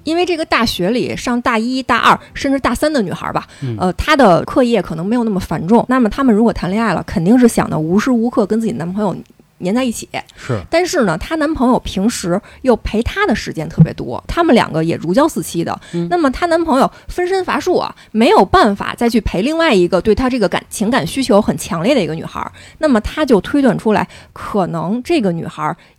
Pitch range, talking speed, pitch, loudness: 190-275 Hz, 330 characters per minute, 230 Hz, -15 LUFS